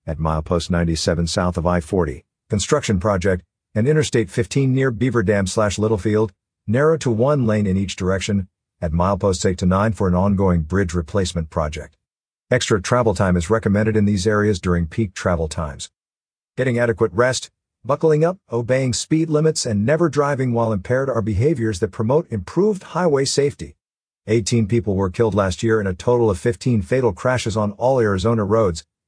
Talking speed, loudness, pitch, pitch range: 170 wpm, -19 LUFS, 110 Hz, 90-120 Hz